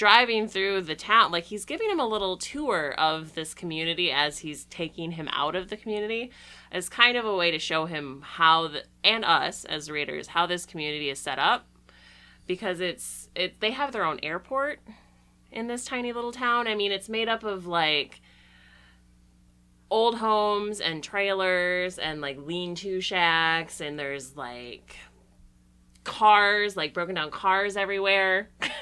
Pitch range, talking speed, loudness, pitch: 150-210 Hz, 165 wpm, -26 LUFS, 175 Hz